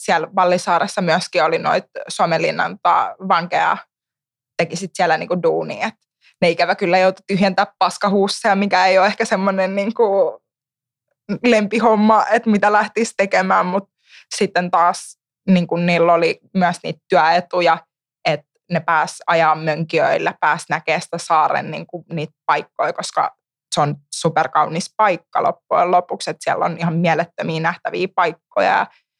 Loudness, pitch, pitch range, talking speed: -18 LUFS, 175 Hz, 165-200 Hz, 125 wpm